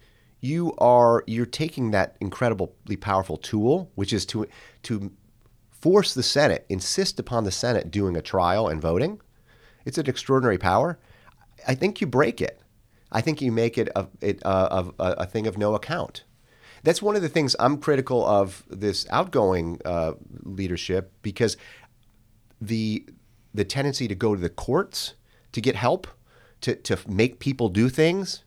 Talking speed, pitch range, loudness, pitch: 160 wpm, 100-125 Hz, -24 LUFS, 115 Hz